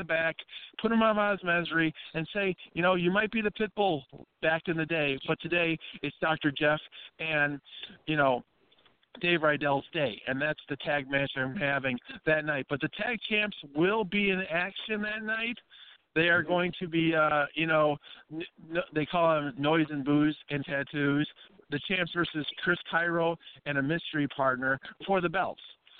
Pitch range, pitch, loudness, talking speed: 145-180 Hz, 160 Hz, -29 LUFS, 185 wpm